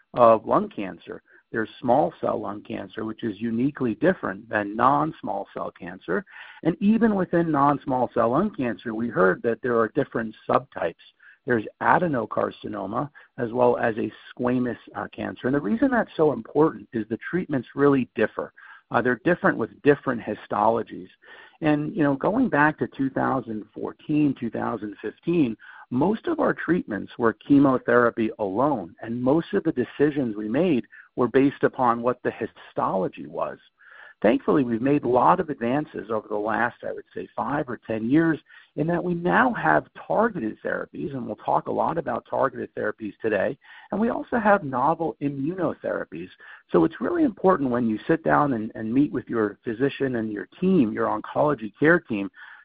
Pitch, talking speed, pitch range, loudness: 130 Hz, 170 wpm, 115-160 Hz, -24 LUFS